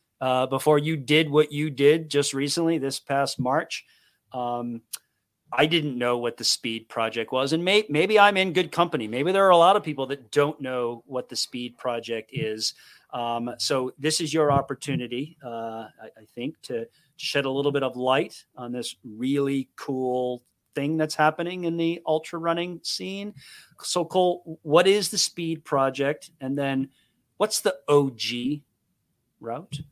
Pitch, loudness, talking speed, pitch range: 140 Hz, -25 LUFS, 170 wpm, 125-160 Hz